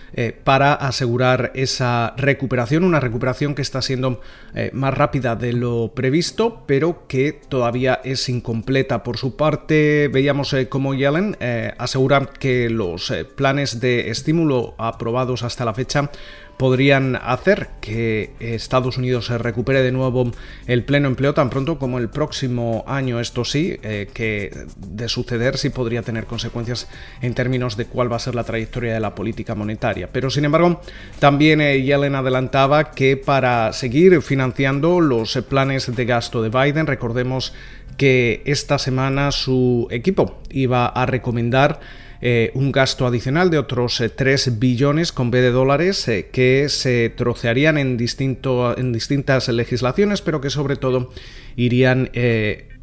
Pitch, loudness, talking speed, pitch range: 130 Hz, -19 LUFS, 155 wpm, 120-140 Hz